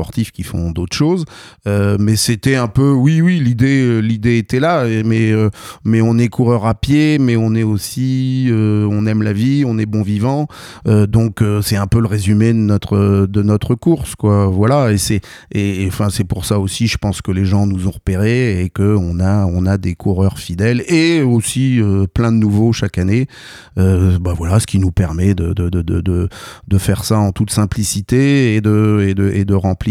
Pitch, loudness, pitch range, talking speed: 105 Hz, -15 LUFS, 100-120 Hz, 225 wpm